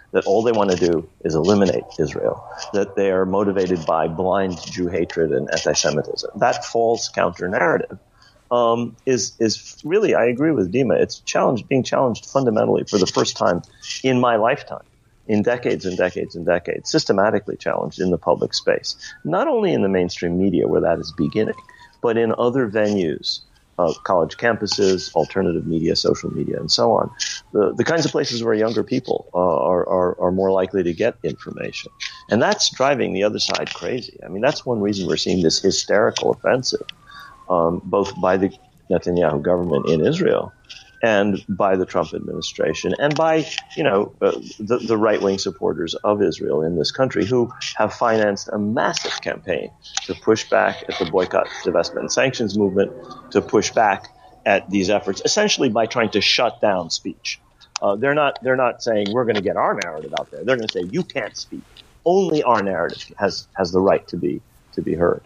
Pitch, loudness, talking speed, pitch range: 105 Hz, -20 LUFS, 190 wpm, 95-120 Hz